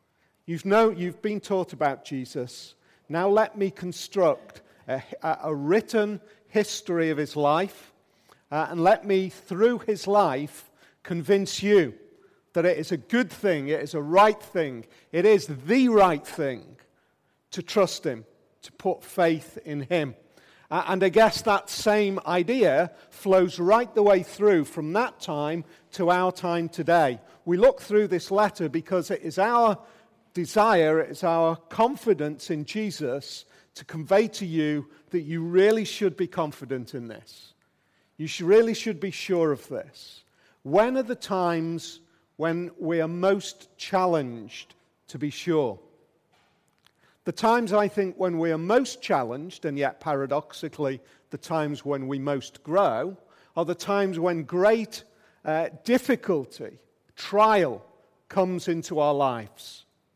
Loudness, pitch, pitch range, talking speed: -25 LUFS, 180 Hz, 155-205 Hz, 145 wpm